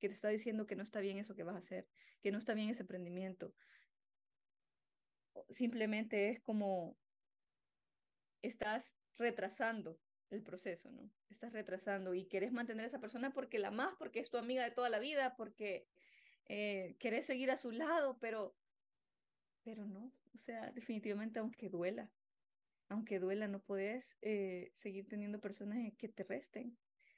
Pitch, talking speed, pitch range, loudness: 215 Hz, 160 wpm, 200-240 Hz, -44 LUFS